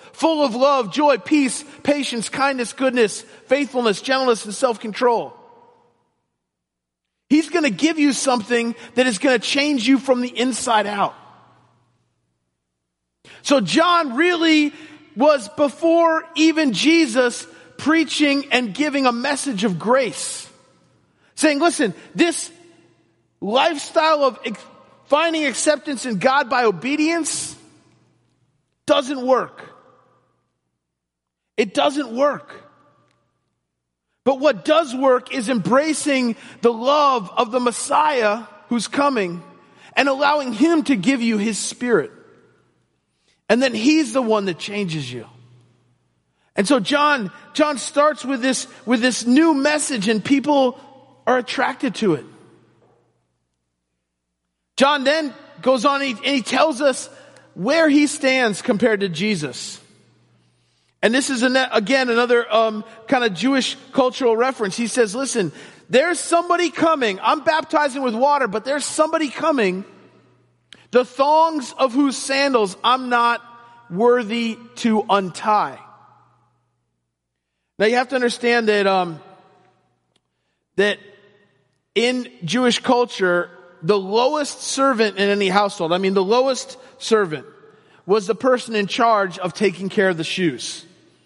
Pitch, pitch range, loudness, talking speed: 250 Hz, 205-285 Hz, -19 LUFS, 125 wpm